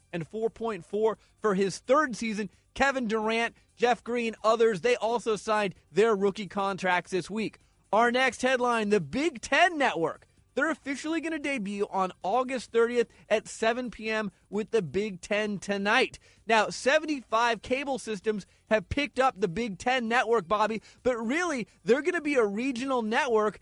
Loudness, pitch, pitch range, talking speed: -28 LUFS, 225 Hz, 210-255 Hz, 160 wpm